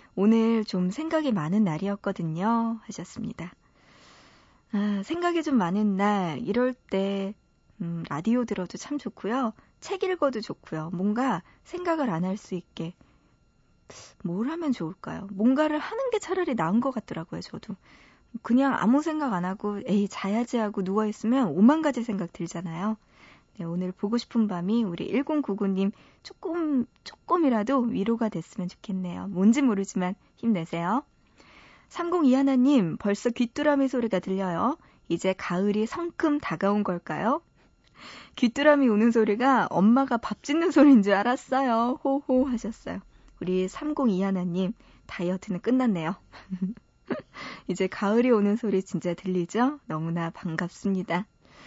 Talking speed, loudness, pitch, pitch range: 280 characters per minute, -26 LUFS, 215 Hz, 190-260 Hz